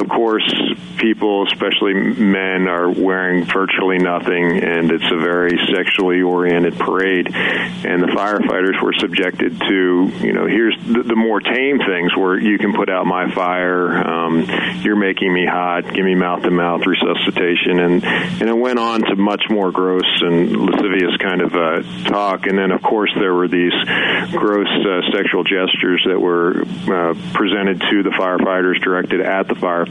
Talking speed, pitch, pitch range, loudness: 170 wpm, 90 Hz, 90-95 Hz, -16 LUFS